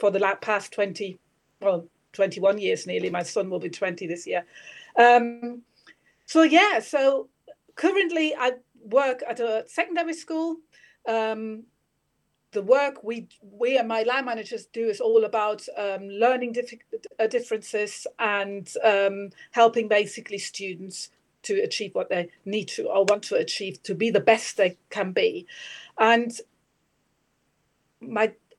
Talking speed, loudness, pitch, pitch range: 140 wpm, -24 LUFS, 220 Hz, 200-255 Hz